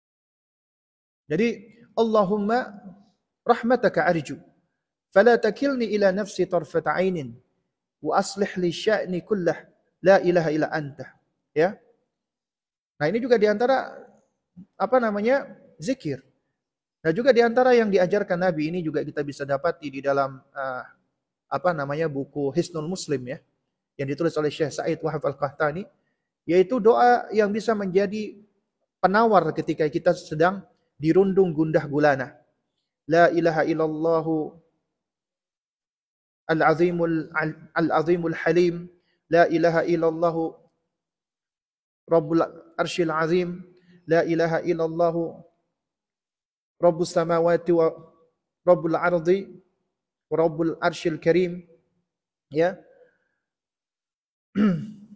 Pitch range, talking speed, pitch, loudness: 160-195 Hz, 100 wpm, 170 Hz, -23 LUFS